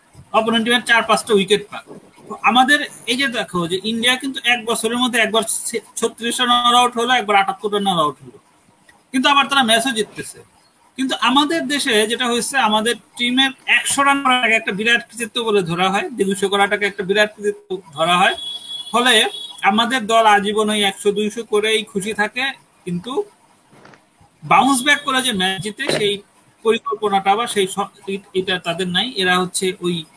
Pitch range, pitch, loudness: 200-250 Hz, 225 Hz, -17 LUFS